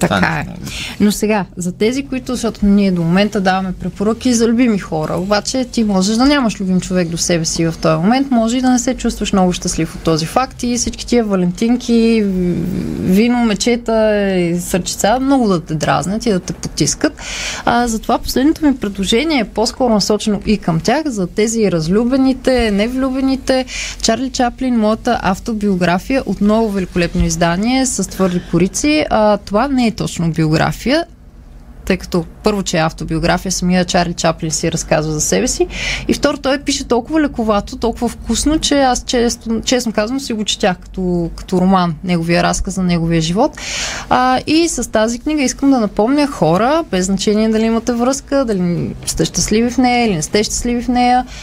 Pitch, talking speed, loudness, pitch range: 215 Hz, 175 wpm, -15 LUFS, 180-245 Hz